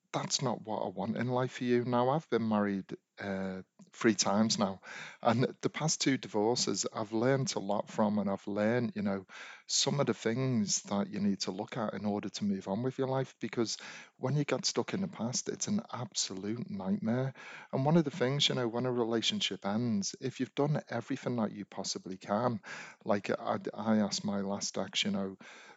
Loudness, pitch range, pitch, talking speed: -33 LUFS, 105-135 Hz, 120 Hz, 210 wpm